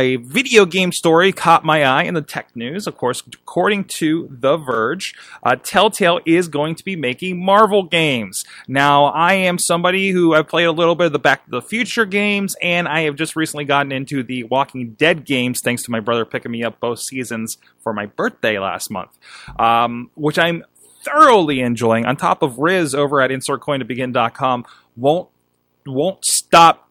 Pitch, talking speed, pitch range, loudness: 150 Hz, 185 wpm, 125-175 Hz, -16 LUFS